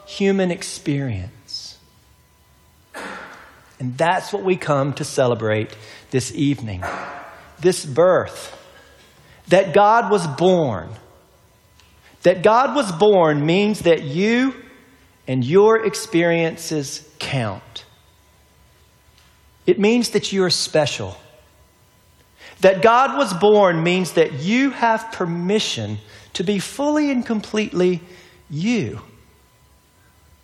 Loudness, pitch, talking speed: -18 LUFS, 165 Hz, 95 wpm